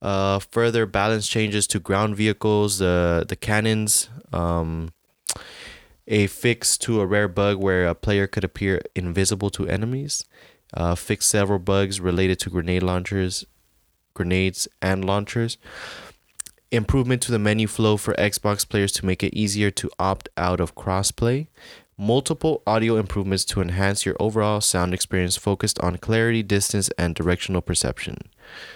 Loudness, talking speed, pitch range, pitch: -22 LUFS, 145 wpm, 95-105 Hz, 100 Hz